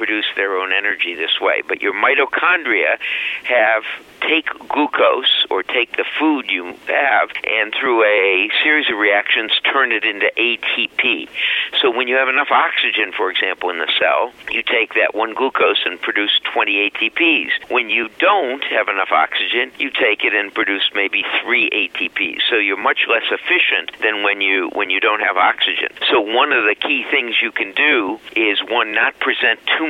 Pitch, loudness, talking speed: 325 Hz, -16 LUFS, 180 wpm